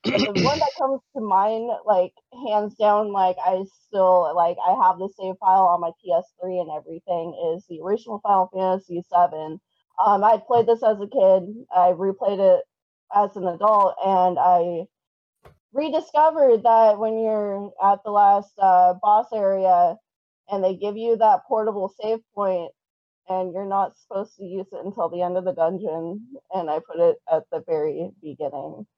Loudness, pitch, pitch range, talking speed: -21 LUFS, 195 Hz, 180-225 Hz, 175 wpm